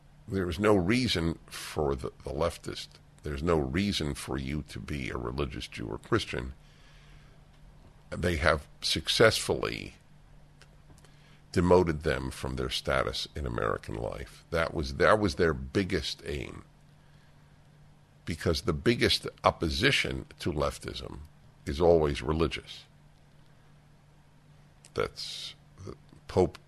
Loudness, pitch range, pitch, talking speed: -30 LUFS, 70-90 Hz, 80 Hz, 110 wpm